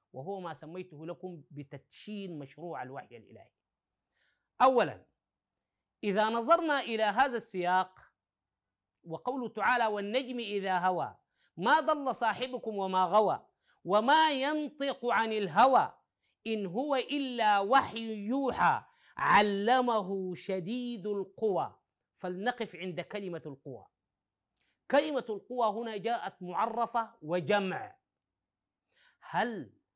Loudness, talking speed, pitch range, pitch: -31 LUFS, 95 wpm, 180-245 Hz, 210 Hz